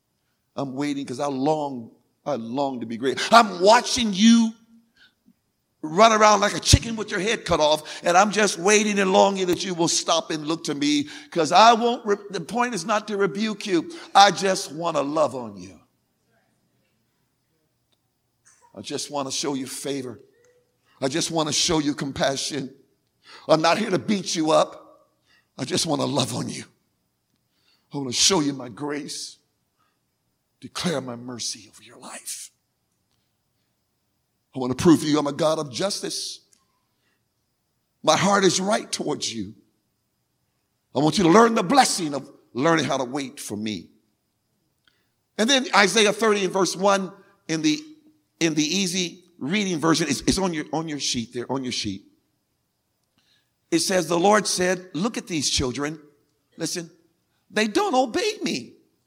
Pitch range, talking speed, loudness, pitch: 145-210 Hz, 170 wpm, -22 LUFS, 170 Hz